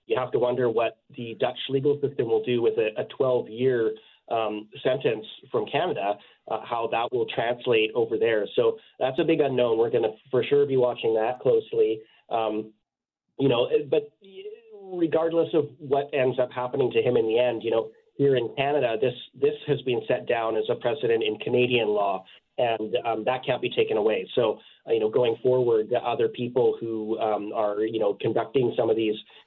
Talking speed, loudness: 195 wpm, -25 LUFS